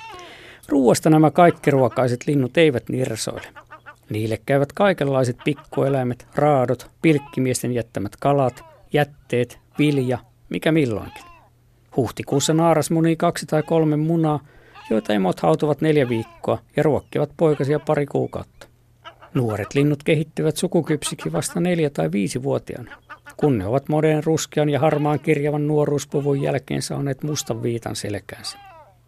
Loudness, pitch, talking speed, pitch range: -21 LUFS, 145 Hz, 120 wpm, 125-155 Hz